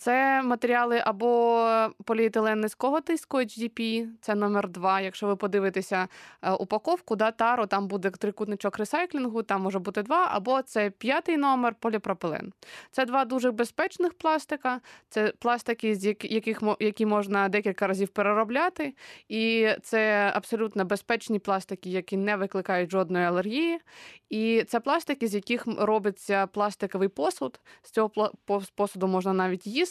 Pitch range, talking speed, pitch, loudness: 200-240 Hz, 130 wpm, 220 Hz, -27 LUFS